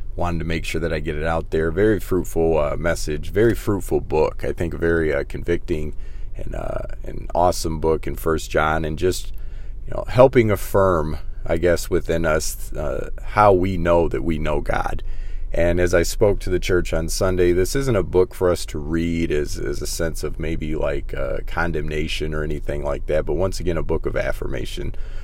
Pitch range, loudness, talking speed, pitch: 80-95 Hz, -22 LUFS, 205 wpm, 85 Hz